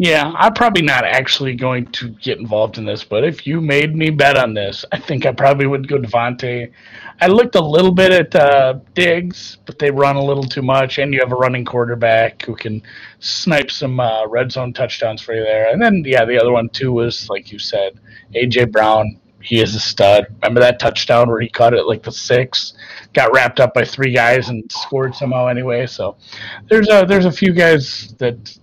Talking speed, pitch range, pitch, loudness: 220 wpm, 115-145 Hz, 130 Hz, -14 LUFS